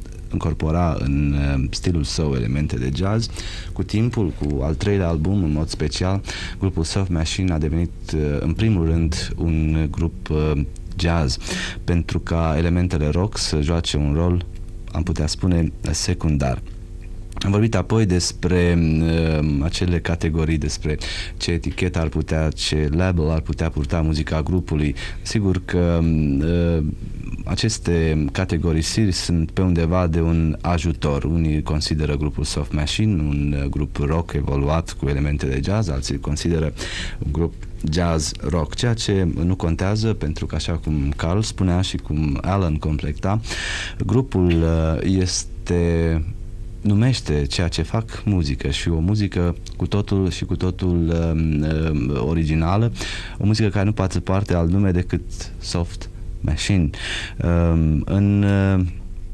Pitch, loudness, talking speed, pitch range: 85 Hz, -21 LUFS, 135 wpm, 80-95 Hz